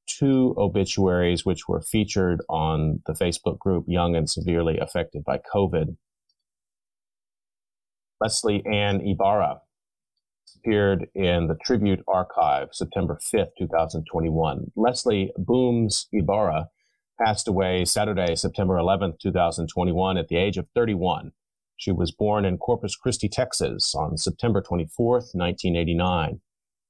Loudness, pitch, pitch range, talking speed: -24 LUFS, 95 Hz, 85-105 Hz, 115 wpm